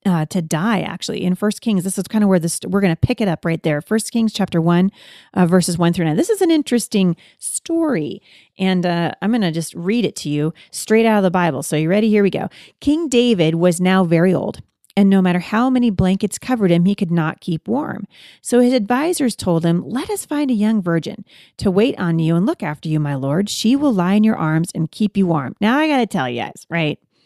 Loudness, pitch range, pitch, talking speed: -18 LUFS, 170-225 Hz, 195 Hz, 245 wpm